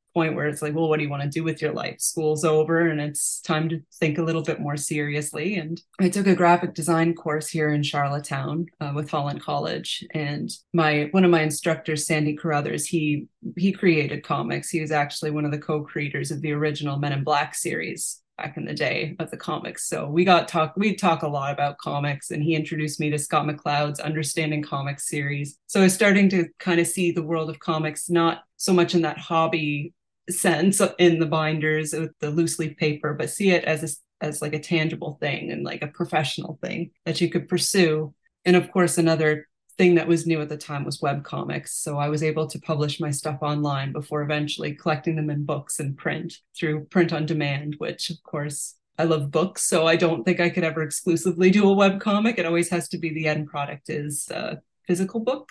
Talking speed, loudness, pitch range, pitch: 220 wpm, -24 LUFS, 150-170 Hz, 155 Hz